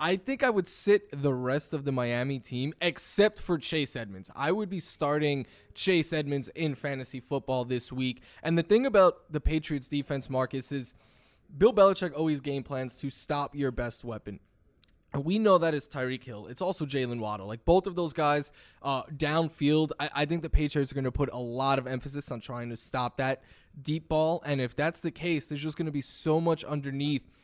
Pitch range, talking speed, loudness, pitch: 130-160 Hz, 210 wpm, -29 LUFS, 145 Hz